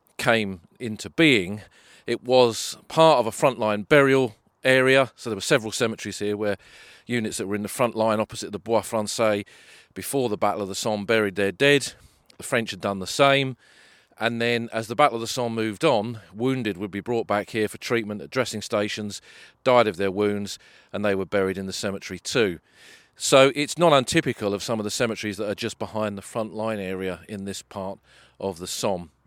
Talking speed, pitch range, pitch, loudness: 205 wpm, 100-120 Hz, 110 Hz, -23 LUFS